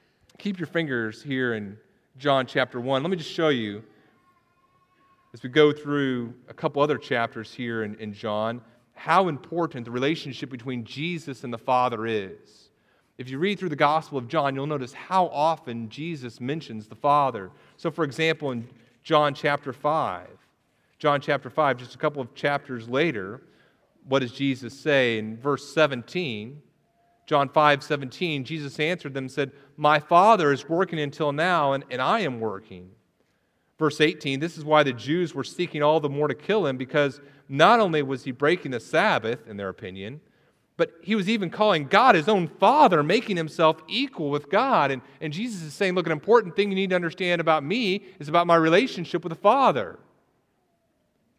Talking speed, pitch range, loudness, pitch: 180 wpm, 130-165 Hz, -24 LUFS, 145 Hz